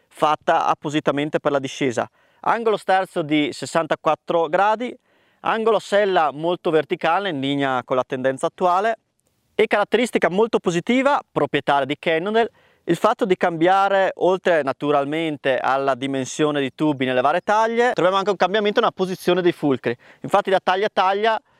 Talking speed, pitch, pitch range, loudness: 145 wpm, 175 Hz, 150-205 Hz, -20 LUFS